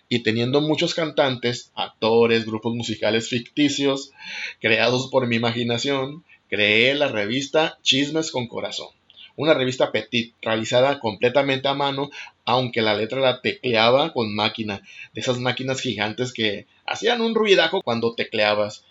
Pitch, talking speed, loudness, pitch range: 125 Hz, 135 wpm, -21 LUFS, 110-140 Hz